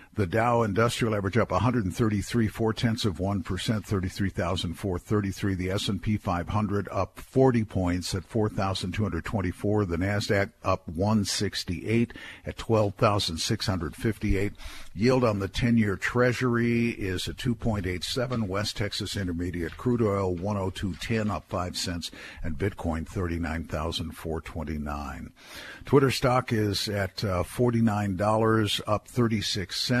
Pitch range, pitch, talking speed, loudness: 90-115 Hz, 100 Hz, 110 wpm, -27 LUFS